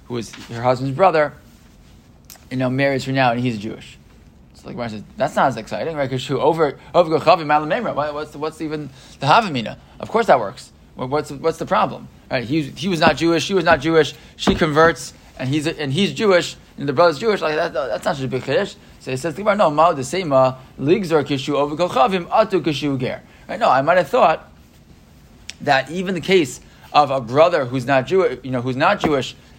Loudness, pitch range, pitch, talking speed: -19 LUFS, 130-165 Hz, 145 Hz, 215 wpm